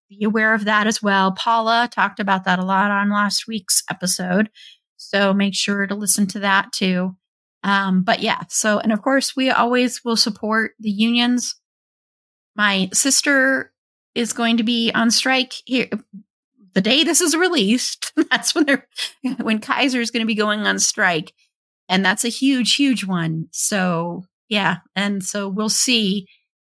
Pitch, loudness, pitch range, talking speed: 215 Hz, -18 LUFS, 195-245 Hz, 170 wpm